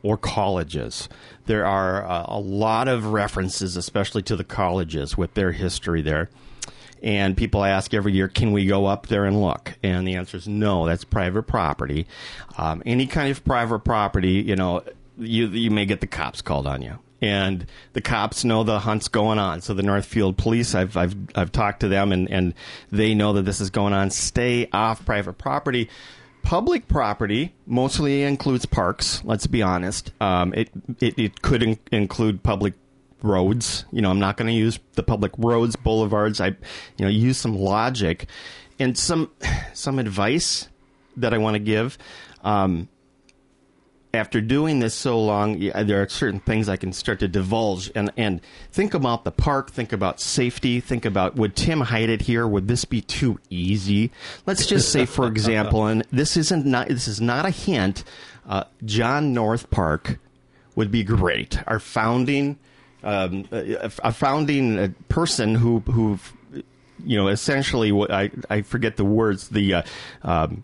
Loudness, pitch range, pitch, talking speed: -22 LUFS, 95-120 Hz, 110 Hz, 175 wpm